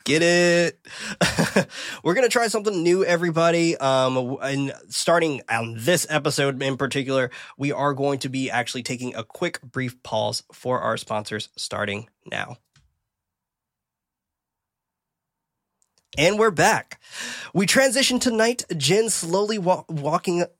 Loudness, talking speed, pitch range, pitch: -22 LUFS, 125 wpm, 130-175 Hz, 145 Hz